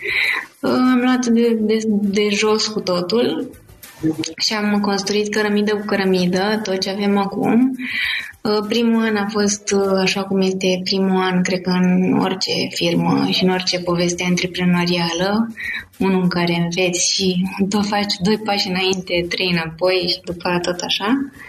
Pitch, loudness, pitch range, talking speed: 195 Hz, -18 LUFS, 180-215 Hz, 150 wpm